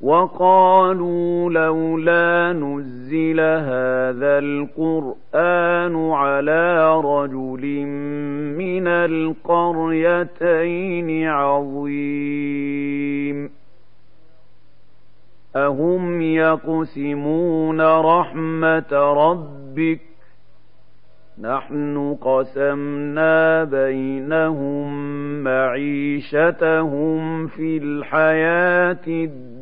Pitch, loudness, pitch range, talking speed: 160 Hz, -19 LUFS, 145-165 Hz, 45 wpm